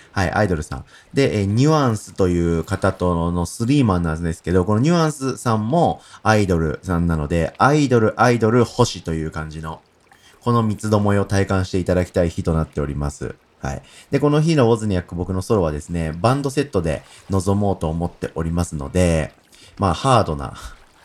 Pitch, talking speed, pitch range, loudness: 95 Hz, 400 characters per minute, 80-110 Hz, -20 LUFS